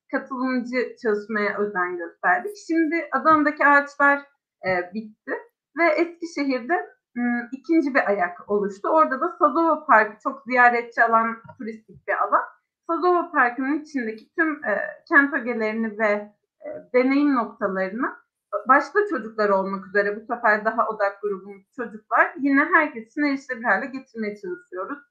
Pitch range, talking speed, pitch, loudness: 215-310 Hz, 115 wpm, 260 Hz, -22 LUFS